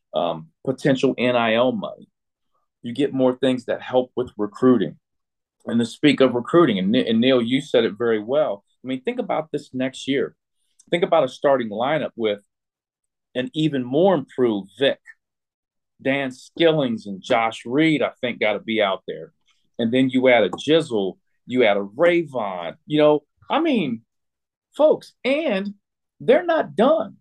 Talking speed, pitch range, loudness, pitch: 165 wpm, 115-160 Hz, -21 LUFS, 130 Hz